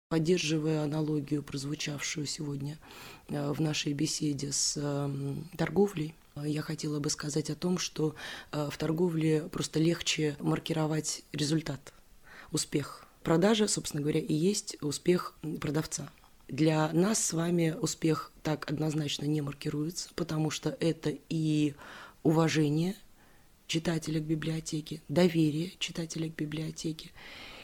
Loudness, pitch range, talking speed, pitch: -31 LUFS, 150-165 Hz, 110 wpm, 155 Hz